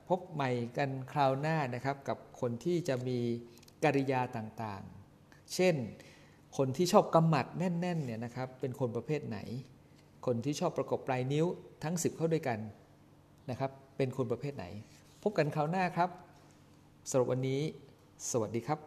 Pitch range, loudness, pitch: 125-155 Hz, -34 LUFS, 135 Hz